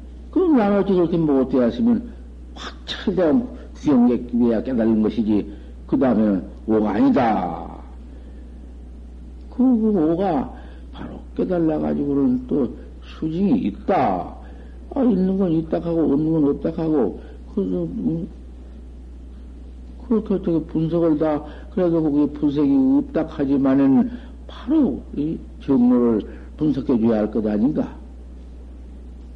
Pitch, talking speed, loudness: 120 Hz, 235 characters per minute, -20 LUFS